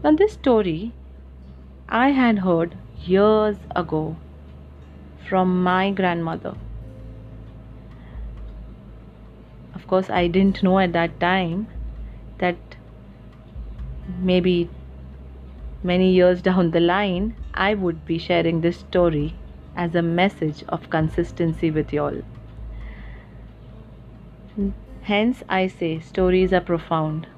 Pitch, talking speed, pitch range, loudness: 170 Hz, 100 wpm, 125-185 Hz, -21 LUFS